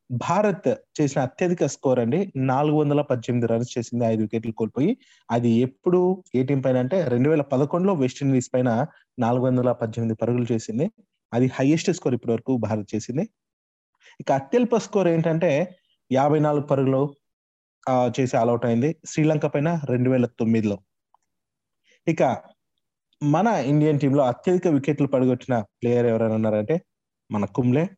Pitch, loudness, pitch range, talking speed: 130 Hz, -23 LUFS, 120-160 Hz, 135 wpm